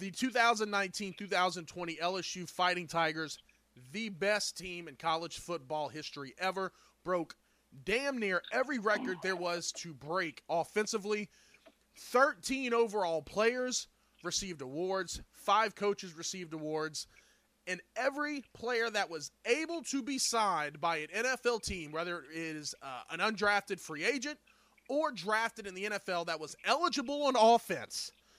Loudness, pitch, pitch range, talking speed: -34 LUFS, 190 Hz, 165-225 Hz, 135 wpm